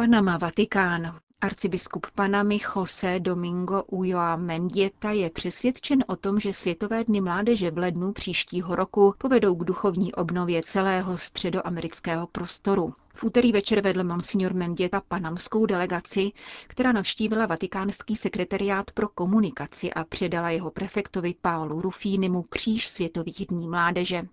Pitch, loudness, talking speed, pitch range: 190 Hz, -26 LUFS, 125 wpm, 175-205 Hz